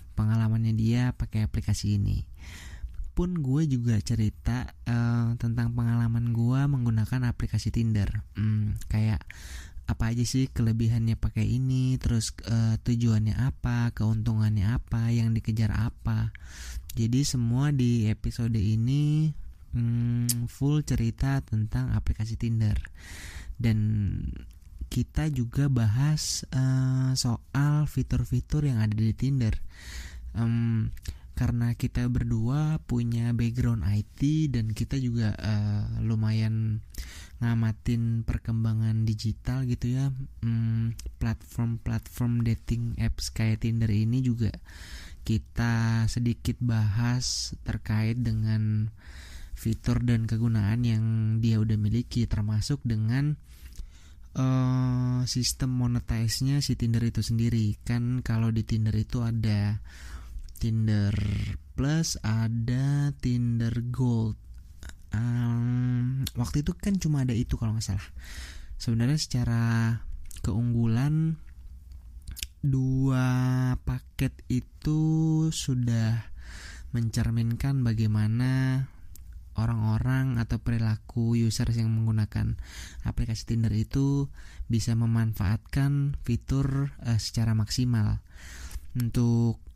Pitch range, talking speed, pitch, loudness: 105-120 Hz, 100 wpm, 115 Hz, -28 LUFS